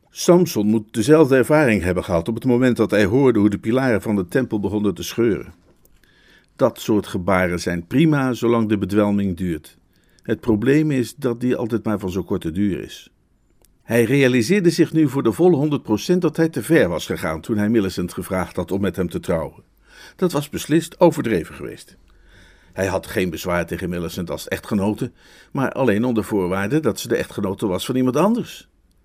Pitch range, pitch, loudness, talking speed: 95-135 Hz, 110 Hz, -20 LUFS, 190 wpm